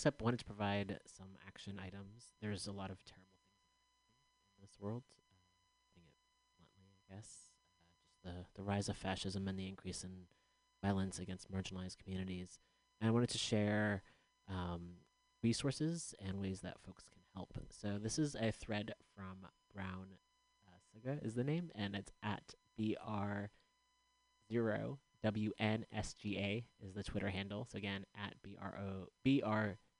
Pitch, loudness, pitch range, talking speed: 100 Hz, -43 LUFS, 95-110 Hz, 140 wpm